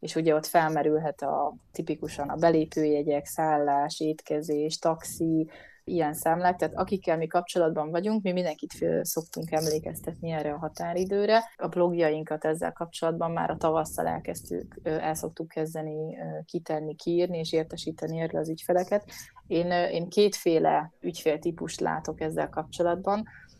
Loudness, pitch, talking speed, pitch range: -28 LUFS, 160 Hz, 125 wpm, 155-175 Hz